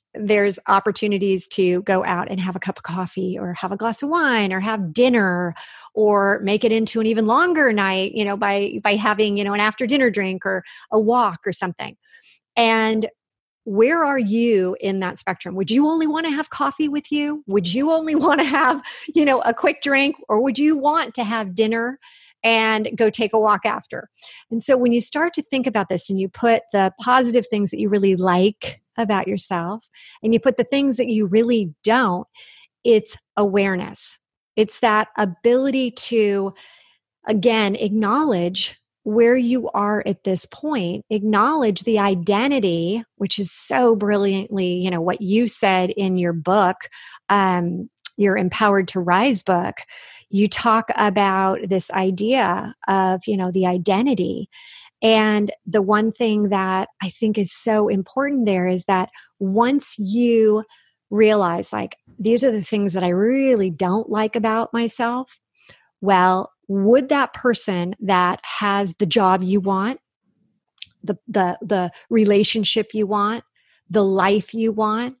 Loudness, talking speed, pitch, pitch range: -19 LUFS, 165 wpm, 215 Hz, 195-240 Hz